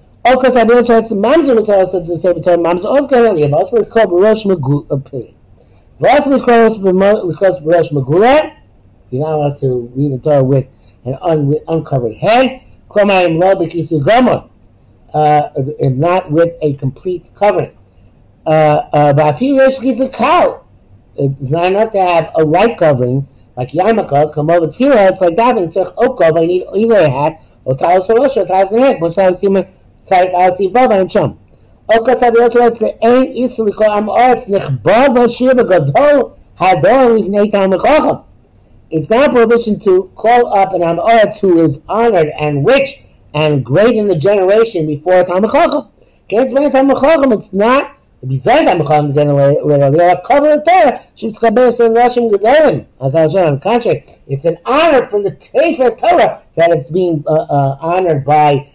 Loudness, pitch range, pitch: -11 LUFS, 150-235 Hz, 185 Hz